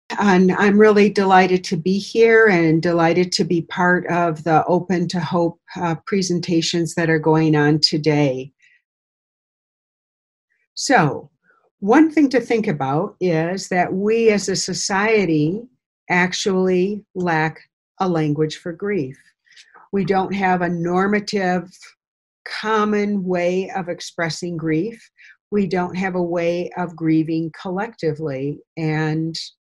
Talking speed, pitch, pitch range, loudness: 125 wpm, 180 Hz, 165-195 Hz, -19 LUFS